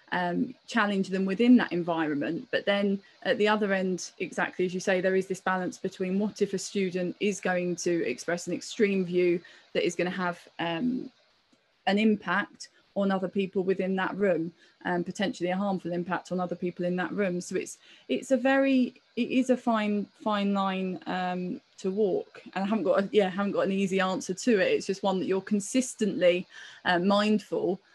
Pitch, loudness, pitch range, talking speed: 190 Hz, -28 LUFS, 180-210 Hz, 200 wpm